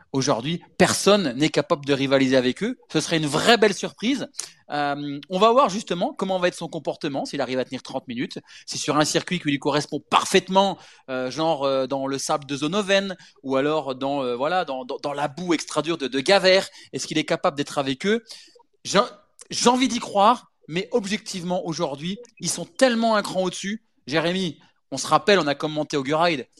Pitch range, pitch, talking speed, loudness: 145-195 Hz, 165 Hz, 205 wpm, -23 LUFS